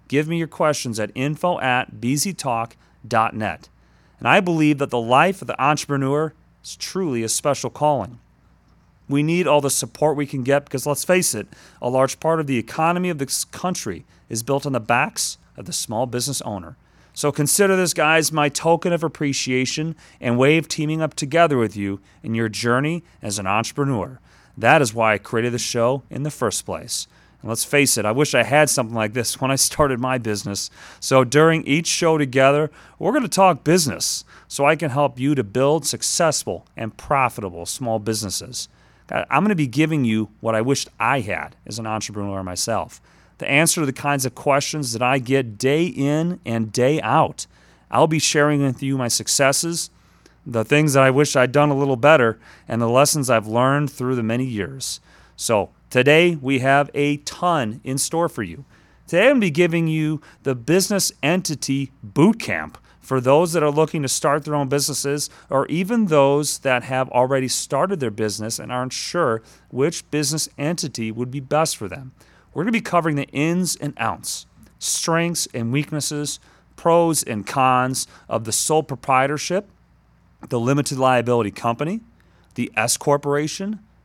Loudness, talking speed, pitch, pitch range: -20 LUFS, 185 wpm, 135 Hz, 120-150 Hz